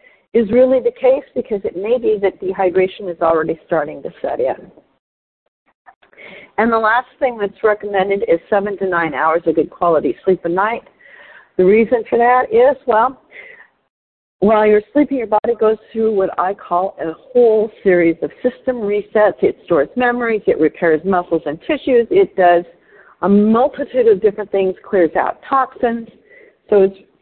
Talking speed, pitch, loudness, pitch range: 165 wpm, 215 Hz, -16 LUFS, 190-255 Hz